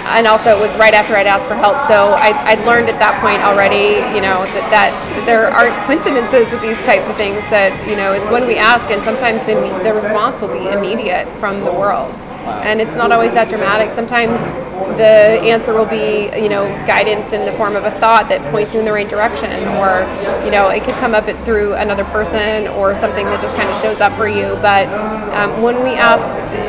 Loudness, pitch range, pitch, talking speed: -13 LUFS, 205-225 Hz, 215 Hz, 225 wpm